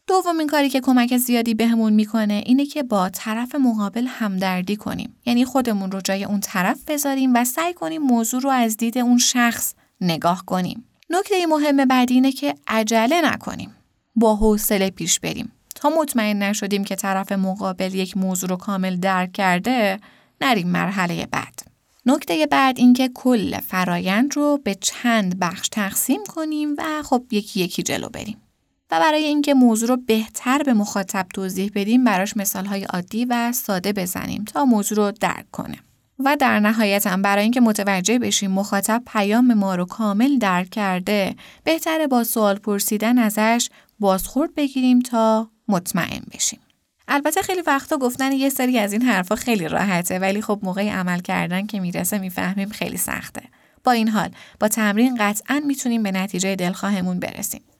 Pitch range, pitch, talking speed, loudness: 195-255 Hz, 220 Hz, 160 wpm, -20 LUFS